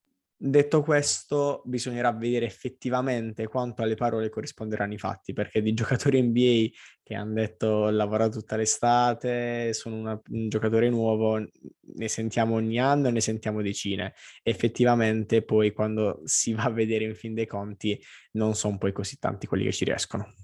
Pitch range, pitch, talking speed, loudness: 110-120 Hz, 110 Hz, 160 wpm, -27 LUFS